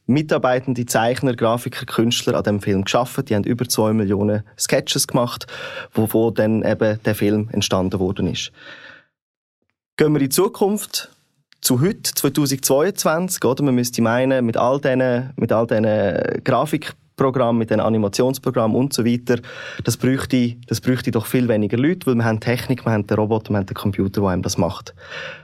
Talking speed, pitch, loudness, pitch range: 160 wpm, 120 Hz, -19 LUFS, 110-130 Hz